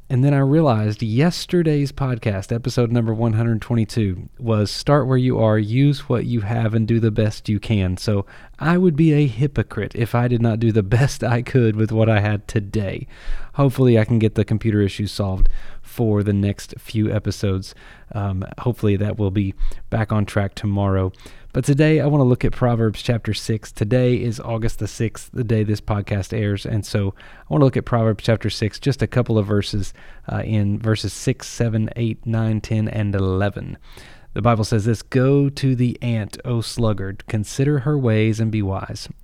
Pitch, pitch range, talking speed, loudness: 110 Hz, 105-125 Hz, 195 wpm, -20 LUFS